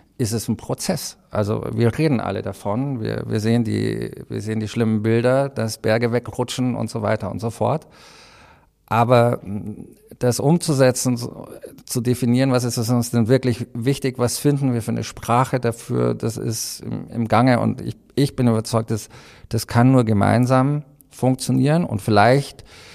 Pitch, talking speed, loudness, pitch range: 120 Hz, 165 wpm, -20 LUFS, 110-130 Hz